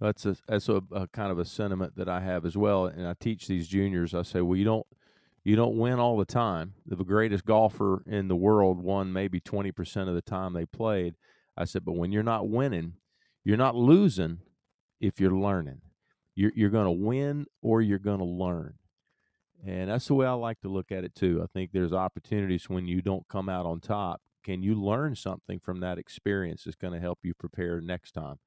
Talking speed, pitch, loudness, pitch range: 220 wpm, 95 Hz, -29 LUFS, 90-105 Hz